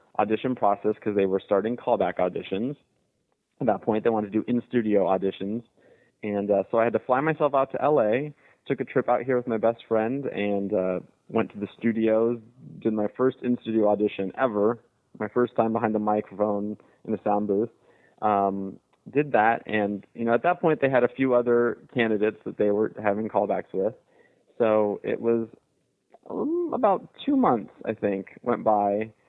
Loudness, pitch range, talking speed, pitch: -25 LUFS, 105-125 Hz, 185 wpm, 110 Hz